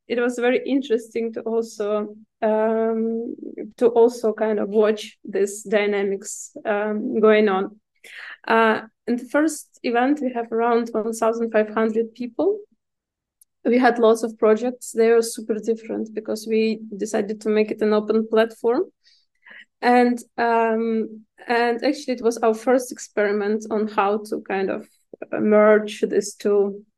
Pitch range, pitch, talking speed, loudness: 215-235 Hz, 225 Hz, 145 wpm, -21 LUFS